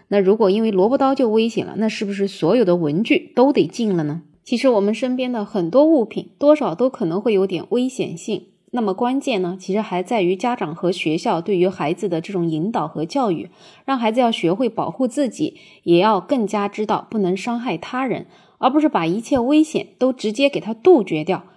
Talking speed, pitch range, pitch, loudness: 315 characters per minute, 185-255 Hz, 215 Hz, -19 LUFS